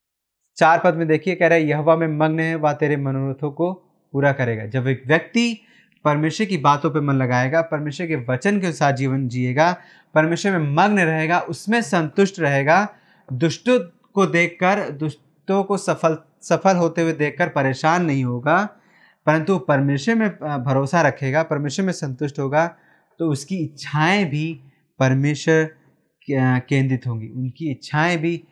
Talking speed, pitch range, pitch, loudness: 155 wpm, 145-175 Hz, 160 Hz, -20 LUFS